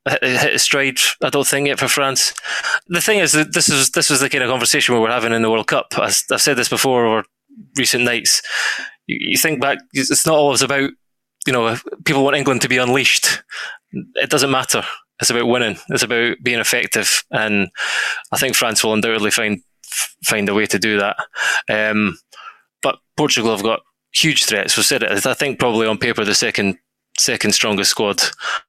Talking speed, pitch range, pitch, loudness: 195 wpm, 115-140 Hz, 130 Hz, -16 LUFS